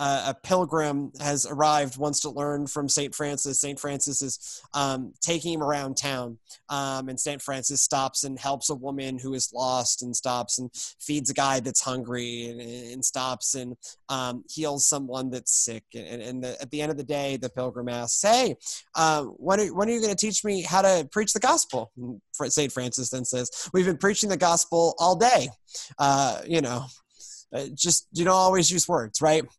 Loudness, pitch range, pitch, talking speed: -25 LUFS, 130-155 Hz, 140 Hz, 195 wpm